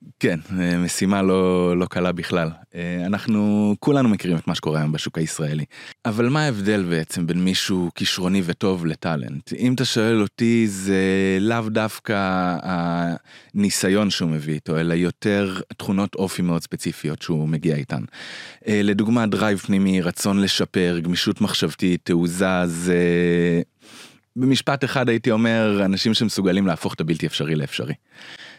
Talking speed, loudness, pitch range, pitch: 135 wpm, -21 LUFS, 85-105 Hz, 95 Hz